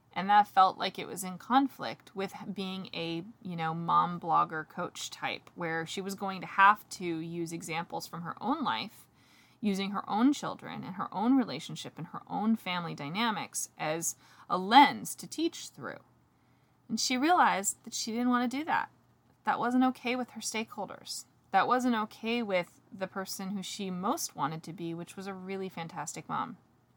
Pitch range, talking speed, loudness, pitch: 170-235 Hz, 185 wpm, -31 LUFS, 195 Hz